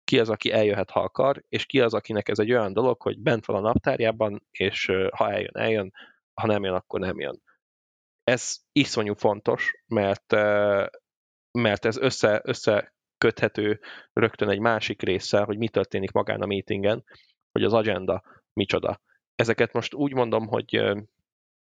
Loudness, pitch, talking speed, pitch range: -25 LUFS, 105 Hz, 155 wpm, 100-115 Hz